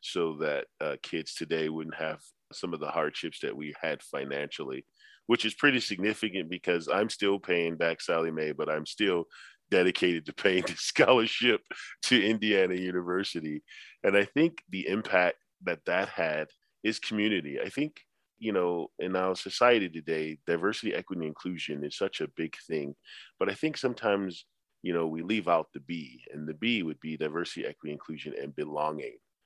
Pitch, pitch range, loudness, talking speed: 90 Hz, 80-110 Hz, -30 LUFS, 170 wpm